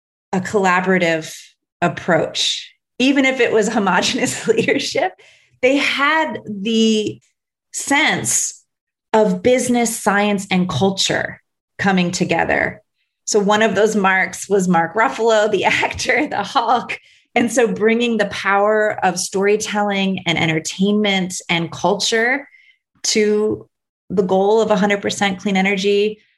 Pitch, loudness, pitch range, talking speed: 205 Hz, -17 LUFS, 190-225 Hz, 115 wpm